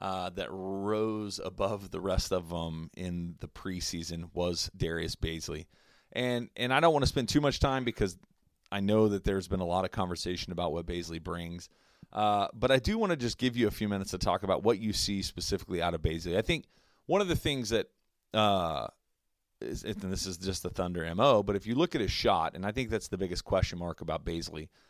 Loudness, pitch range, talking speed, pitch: -31 LUFS, 85-110 Hz, 225 wpm, 95 Hz